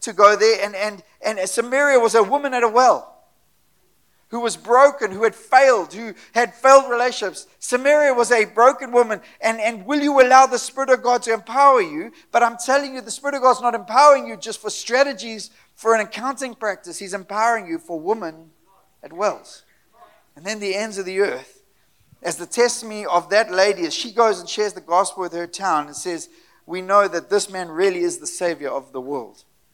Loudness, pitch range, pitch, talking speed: -18 LUFS, 195-260 Hz, 225 Hz, 205 wpm